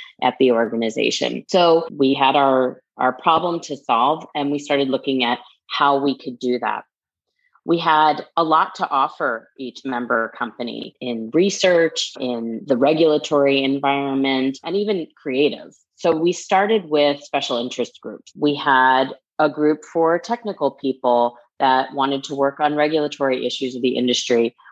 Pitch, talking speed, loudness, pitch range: 140 Hz, 155 wpm, -19 LUFS, 130-160 Hz